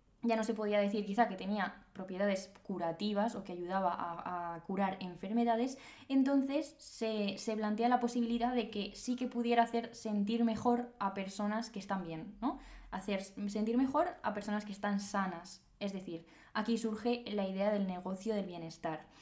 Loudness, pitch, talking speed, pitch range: -36 LUFS, 210 Hz, 170 wpm, 195-235 Hz